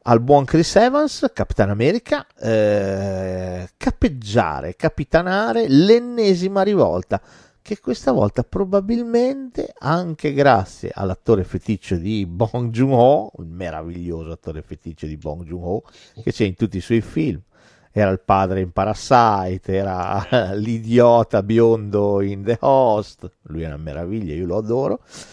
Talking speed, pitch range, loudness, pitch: 130 wpm, 95-140 Hz, -19 LUFS, 110 Hz